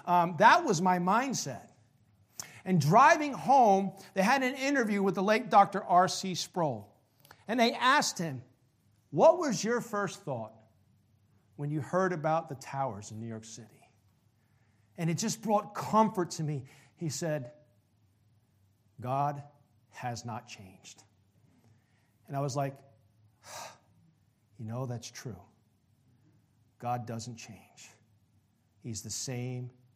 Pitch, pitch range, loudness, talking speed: 125 Hz, 110-175 Hz, -29 LUFS, 130 wpm